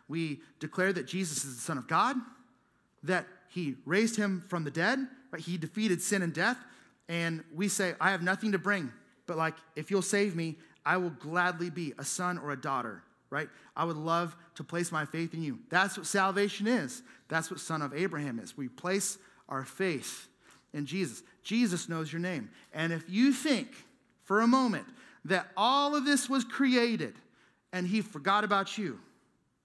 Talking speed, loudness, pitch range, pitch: 190 wpm, -32 LUFS, 160-205 Hz, 180 Hz